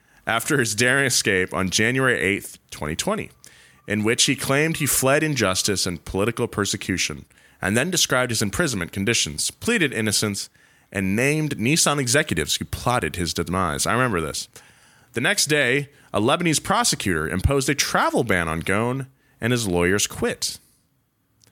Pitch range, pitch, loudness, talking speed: 95-140 Hz, 115 Hz, -21 LUFS, 150 wpm